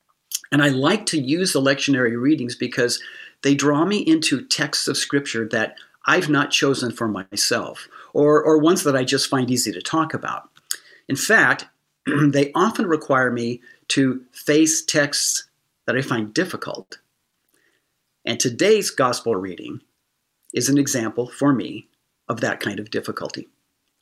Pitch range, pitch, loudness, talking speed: 125-155 Hz, 140 Hz, -20 LUFS, 150 wpm